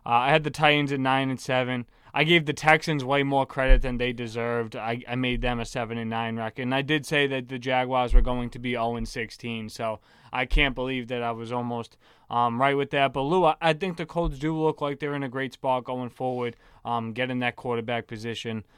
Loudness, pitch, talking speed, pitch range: -26 LUFS, 125 Hz, 245 wpm, 120-140 Hz